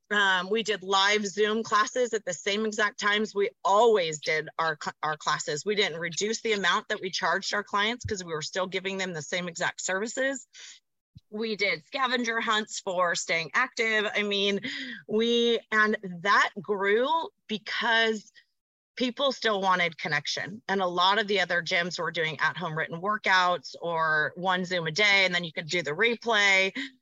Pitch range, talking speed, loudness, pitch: 180-220 Hz, 180 wpm, -26 LUFS, 200 Hz